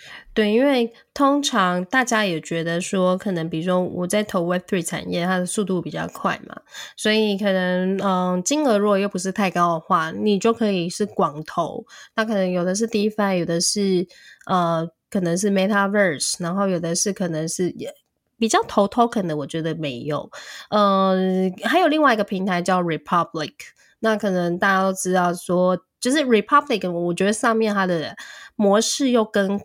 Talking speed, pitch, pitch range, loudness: 315 characters per minute, 190 Hz, 180-215 Hz, -21 LUFS